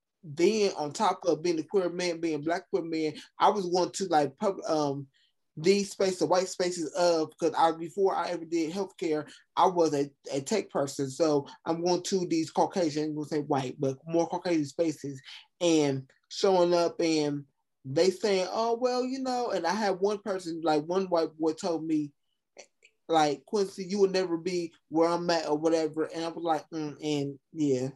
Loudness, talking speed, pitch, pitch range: -29 LUFS, 195 wpm, 165 Hz, 150-185 Hz